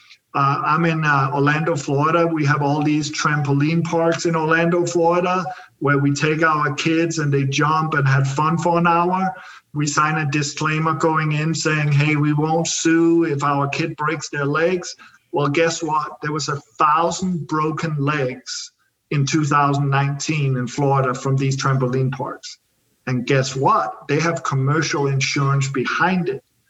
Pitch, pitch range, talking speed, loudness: 150 Hz, 140-165 Hz, 160 wpm, -19 LUFS